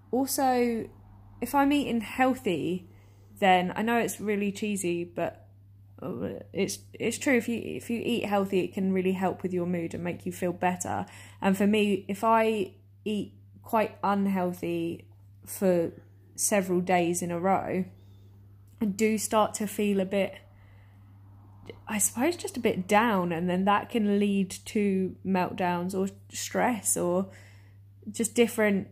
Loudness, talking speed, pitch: -28 LUFS, 150 wpm, 185 Hz